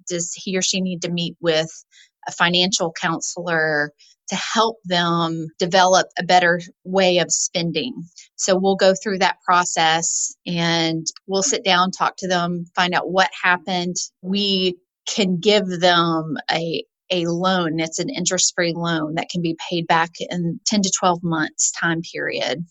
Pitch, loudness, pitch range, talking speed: 180 Hz, -20 LUFS, 170-185 Hz, 160 wpm